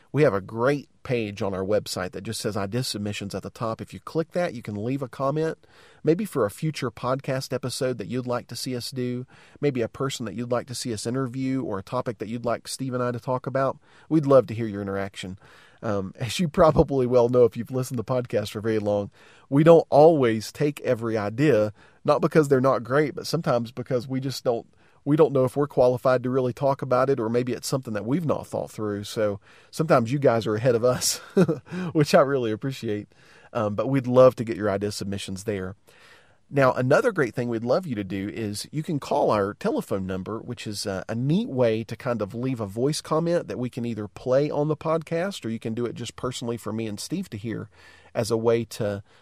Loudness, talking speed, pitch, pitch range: -25 LUFS, 235 wpm, 125 Hz, 110-135 Hz